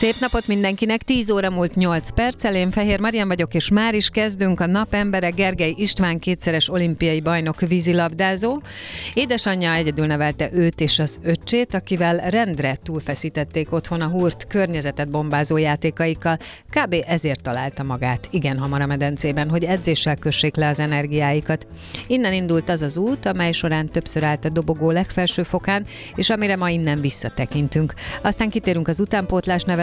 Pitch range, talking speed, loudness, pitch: 155-190 Hz, 155 wpm, -20 LUFS, 170 Hz